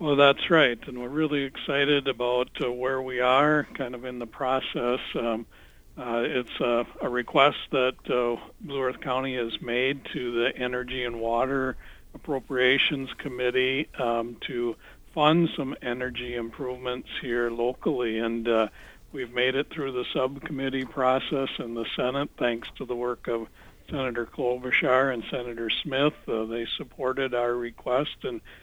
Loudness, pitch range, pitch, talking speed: -27 LUFS, 120-135 Hz, 125 Hz, 155 wpm